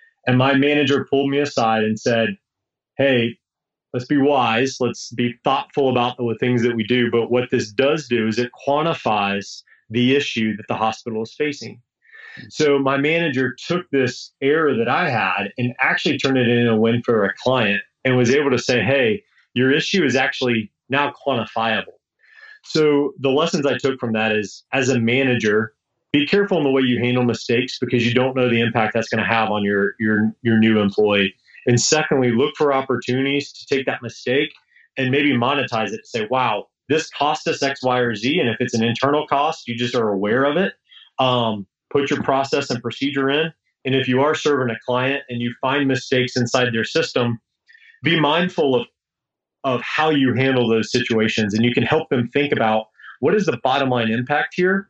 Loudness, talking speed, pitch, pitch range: -19 LUFS, 200 wpm, 125 Hz, 115-140 Hz